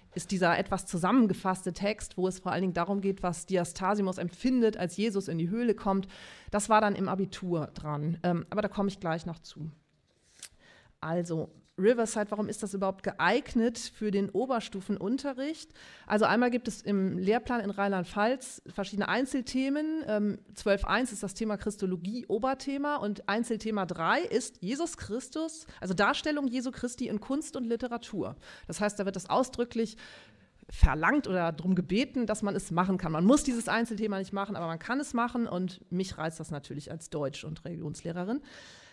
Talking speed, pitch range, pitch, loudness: 170 wpm, 180-235 Hz, 200 Hz, -31 LUFS